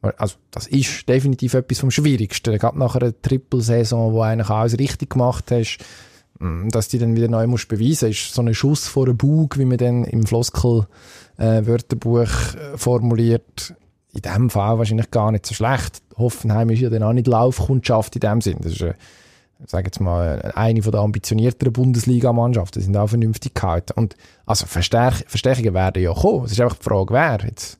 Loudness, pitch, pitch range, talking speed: -19 LUFS, 115 Hz, 110-125 Hz, 180 wpm